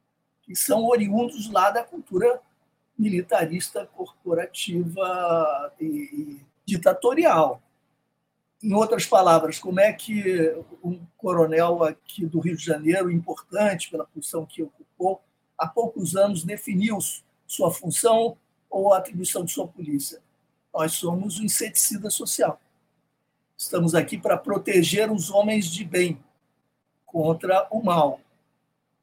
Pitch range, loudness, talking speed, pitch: 165-210 Hz, -23 LUFS, 120 wpm, 180 Hz